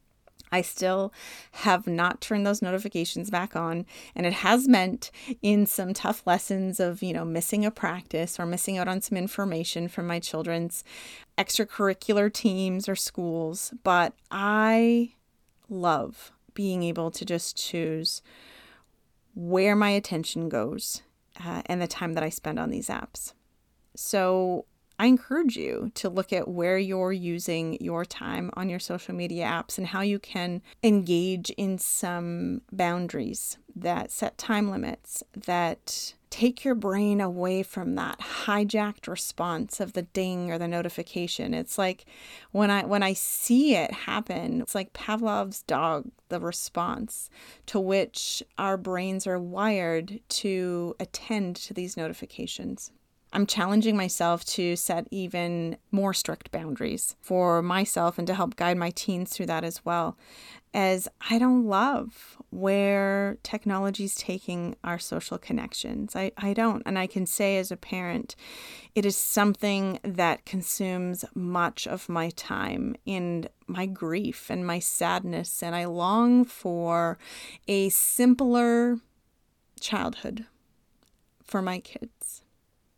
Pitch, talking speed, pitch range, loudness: 190 Hz, 140 wpm, 175-210 Hz, -28 LUFS